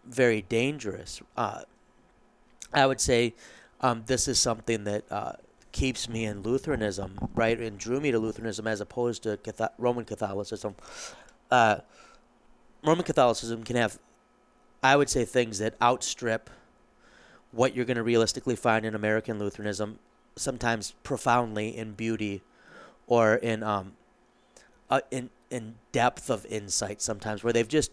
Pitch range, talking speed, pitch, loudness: 110-125 Hz, 140 wpm, 115 Hz, -28 LUFS